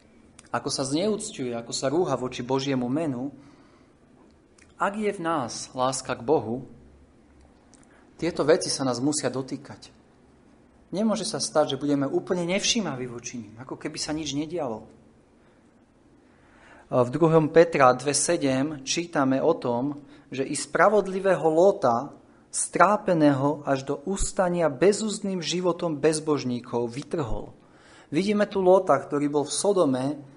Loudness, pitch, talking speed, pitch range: -25 LUFS, 145 Hz, 125 wpm, 130-175 Hz